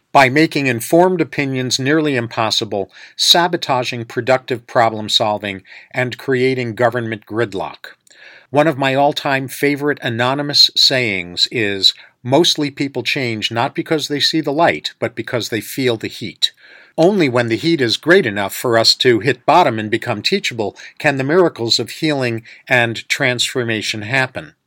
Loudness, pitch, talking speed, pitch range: -16 LUFS, 125 Hz, 150 wpm, 115-145 Hz